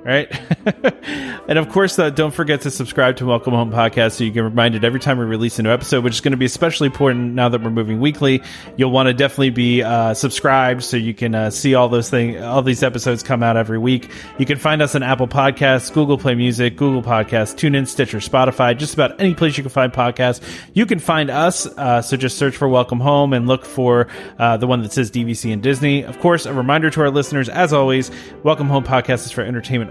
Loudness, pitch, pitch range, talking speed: -17 LUFS, 130 Hz, 120-140 Hz, 240 wpm